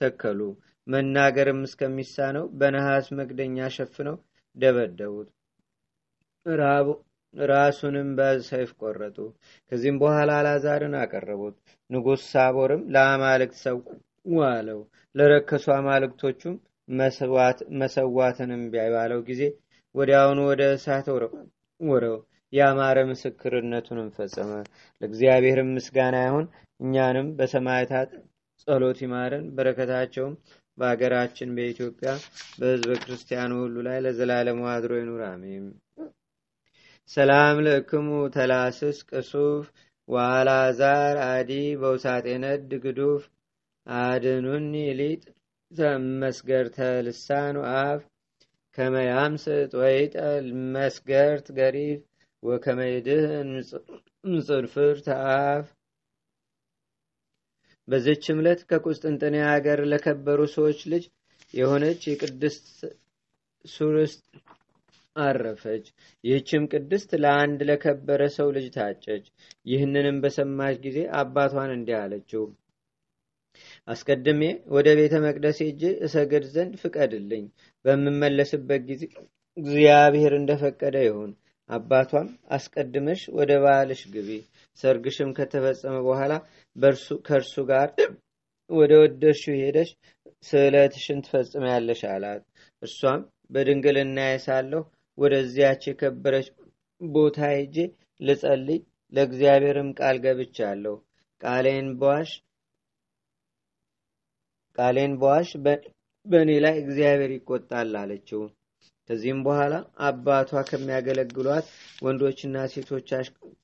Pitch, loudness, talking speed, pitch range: 140 Hz, -24 LUFS, 80 wpm, 130-145 Hz